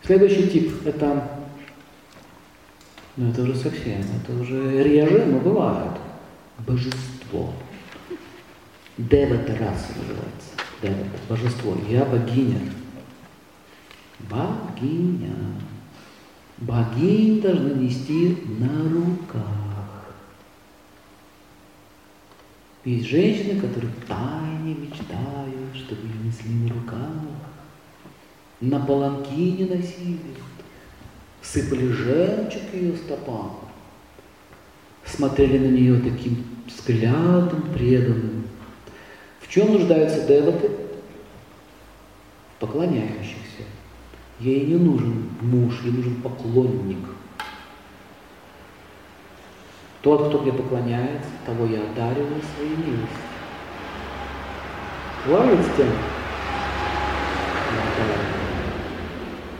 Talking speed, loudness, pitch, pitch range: 70 wpm, -23 LUFS, 120 Hz, 105-145 Hz